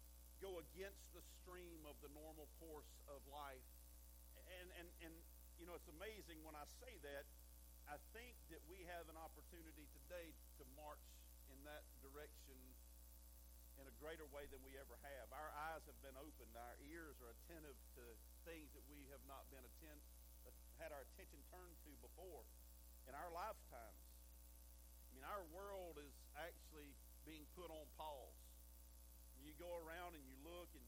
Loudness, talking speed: -59 LUFS, 160 wpm